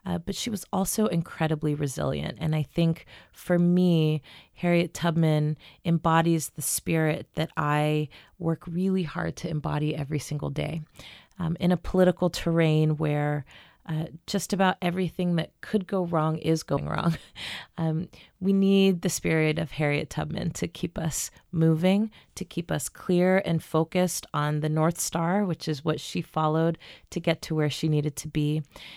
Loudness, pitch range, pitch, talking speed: -27 LUFS, 155-180 Hz, 165 Hz, 165 wpm